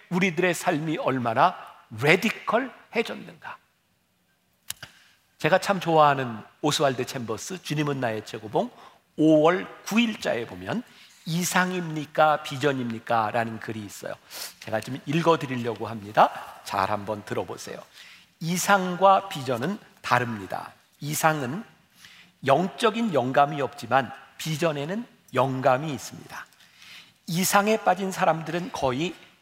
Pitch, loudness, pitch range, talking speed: 155 Hz, -25 LUFS, 125-180 Hz, 255 characters per minute